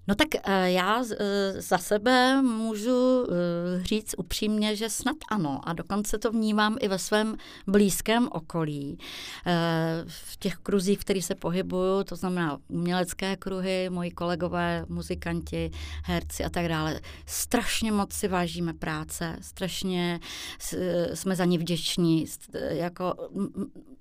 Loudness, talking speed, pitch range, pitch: -28 LUFS, 120 wpm, 170-210 Hz, 185 Hz